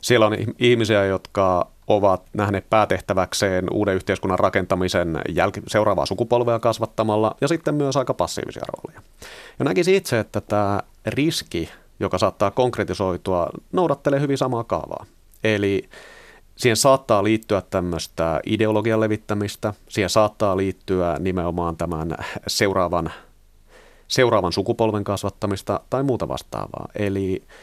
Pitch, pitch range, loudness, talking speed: 105 Hz, 95-115 Hz, -21 LUFS, 115 wpm